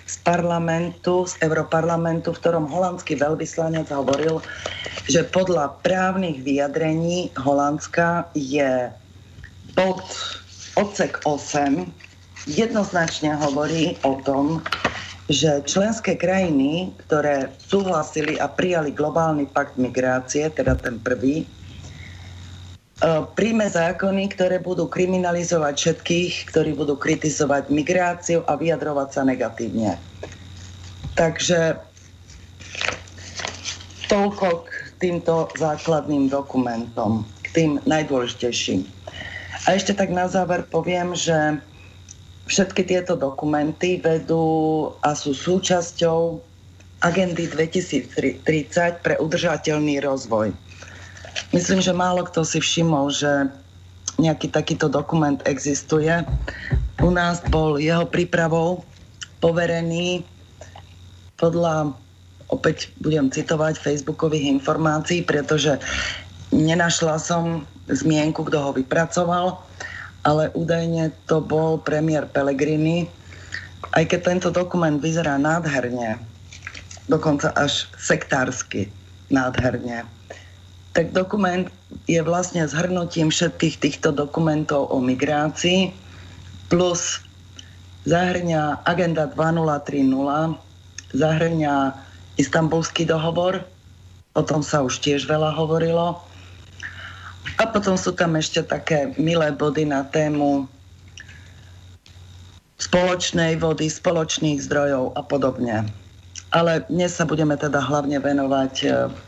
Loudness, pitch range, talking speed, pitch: -21 LUFS, 110-165 Hz, 95 wpm, 150 Hz